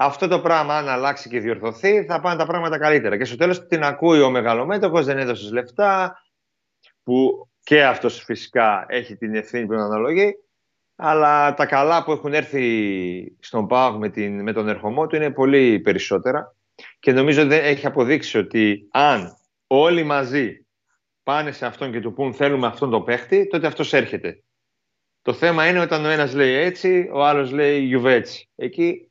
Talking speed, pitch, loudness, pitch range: 170 wpm, 145 Hz, -19 LUFS, 125-165 Hz